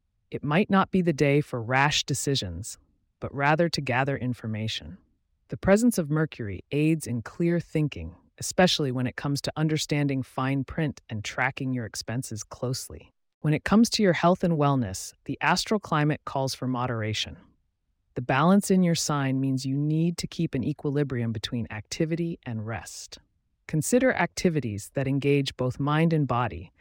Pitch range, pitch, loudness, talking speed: 115-155 Hz, 135 Hz, -26 LUFS, 165 wpm